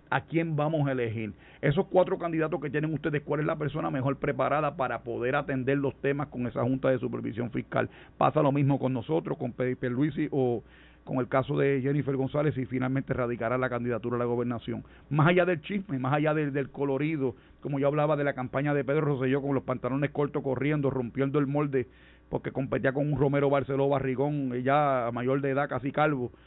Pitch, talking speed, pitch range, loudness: 140 Hz, 205 wpm, 130-150 Hz, -29 LUFS